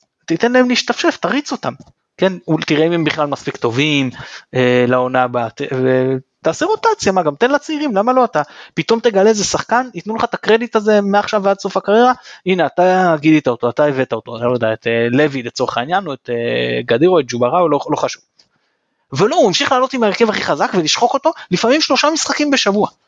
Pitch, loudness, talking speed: 185 Hz, -15 LUFS, 195 wpm